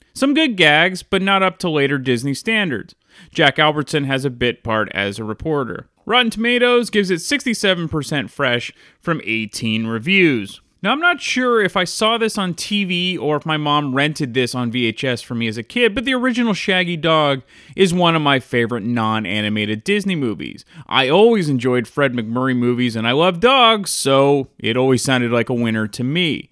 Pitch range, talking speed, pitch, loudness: 120-195 Hz, 190 wpm, 145 Hz, -17 LUFS